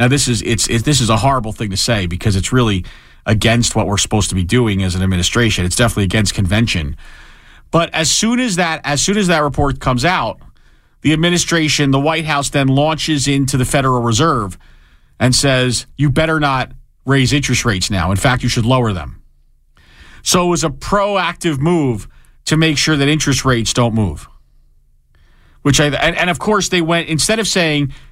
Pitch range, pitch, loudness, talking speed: 110-155 Hz, 130 Hz, -14 LUFS, 195 wpm